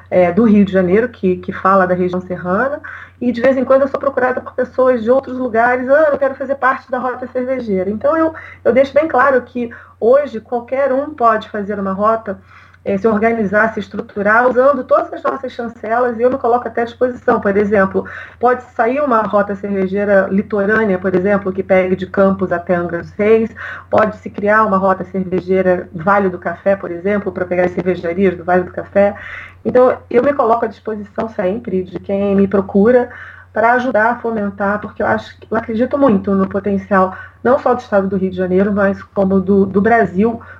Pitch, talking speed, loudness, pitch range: 215 Hz, 200 wpm, -15 LUFS, 195-250 Hz